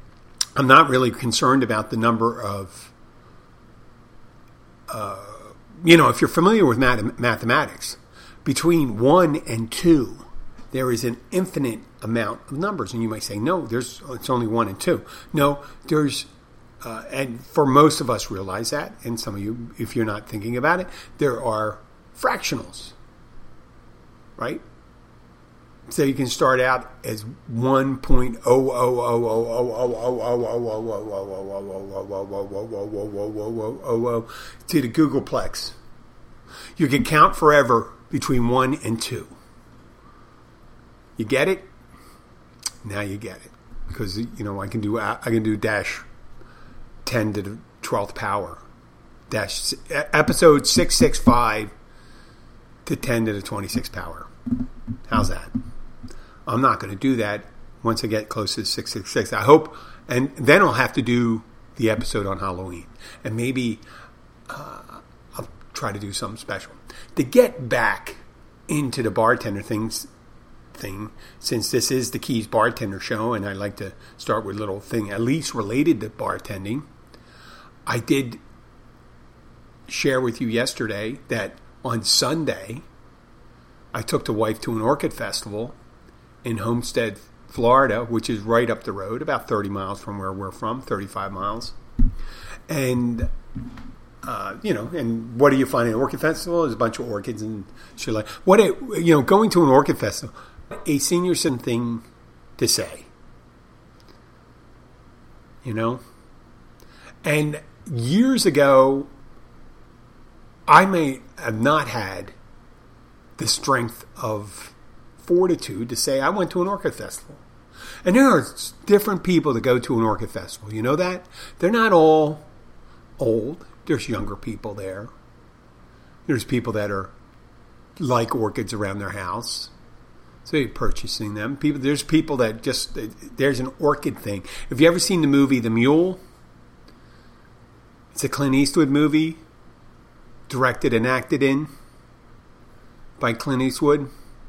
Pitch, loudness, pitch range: 115 Hz, -21 LUFS, 105-135 Hz